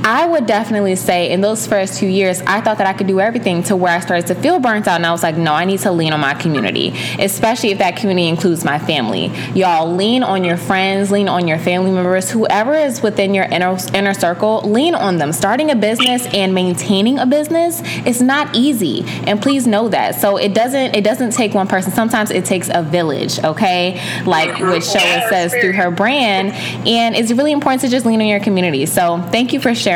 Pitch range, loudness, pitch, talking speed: 180-230 Hz, -14 LUFS, 200 Hz, 225 wpm